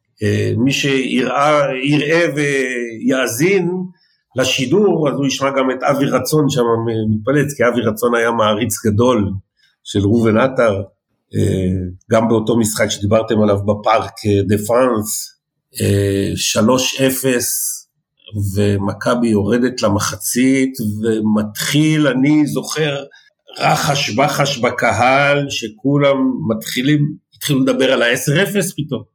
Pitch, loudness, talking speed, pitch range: 125 Hz, -16 LUFS, 105 wpm, 110-140 Hz